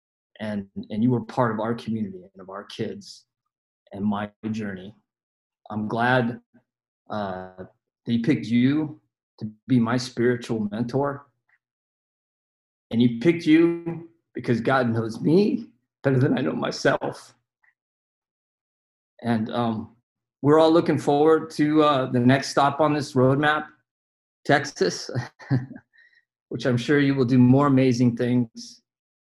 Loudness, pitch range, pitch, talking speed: -23 LUFS, 110-145 Hz, 125 Hz, 130 wpm